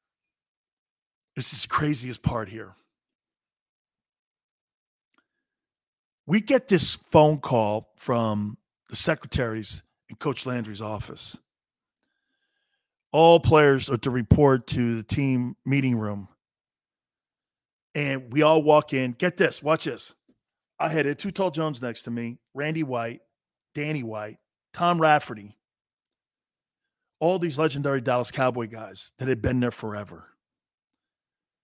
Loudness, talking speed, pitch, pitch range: -24 LUFS, 120 wpm, 135 Hz, 115-155 Hz